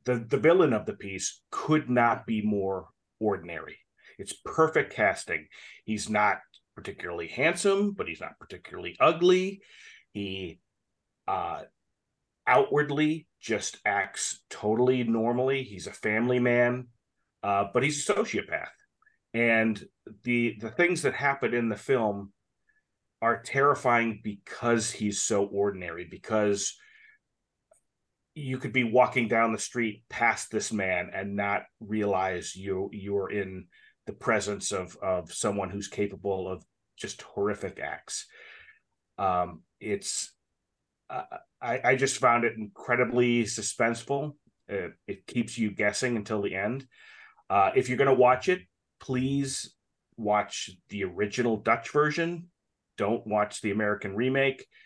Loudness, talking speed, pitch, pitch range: -28 LUFS, 130 wpm, 115 Hz, 105-135 Hz